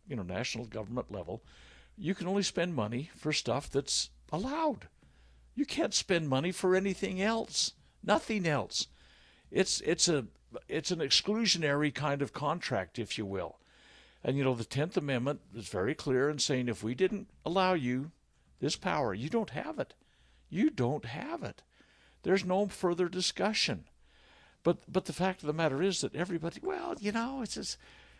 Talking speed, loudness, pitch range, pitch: 170 wpm, -33 LUFS, 125-190 Hz, 160 Hz